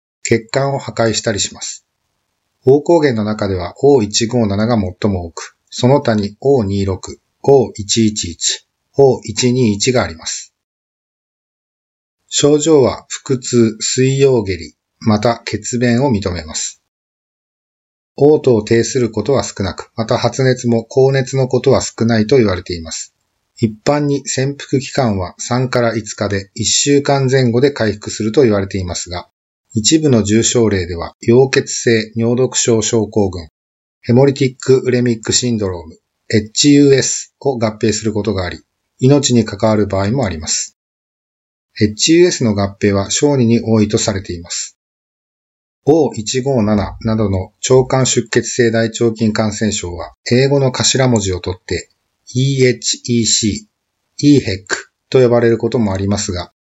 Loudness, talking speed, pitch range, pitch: -14 LUFS, 260 characters per minute, 100-130 Hz, 115 Hz